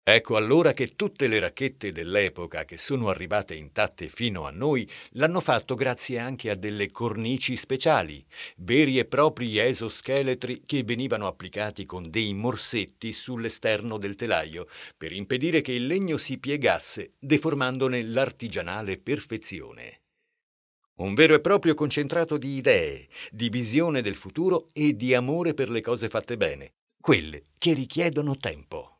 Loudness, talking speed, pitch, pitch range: -26 LUFS, 140 wpm, 125 Hz, 110-150 Hz